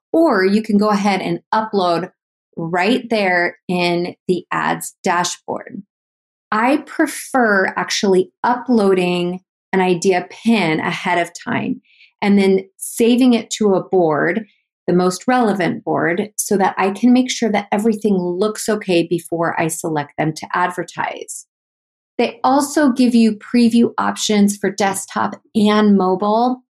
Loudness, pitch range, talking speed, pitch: -17 LUFS, 180-230 Hz, 135 wpm, 200 Hz